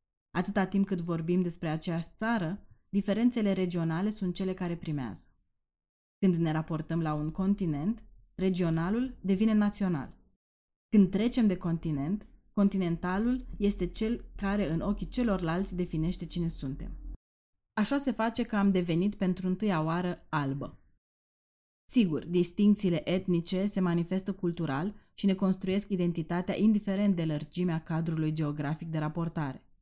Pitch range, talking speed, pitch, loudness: 165-200 Hz, 125 wpm, 180 Hz, -31 LUFS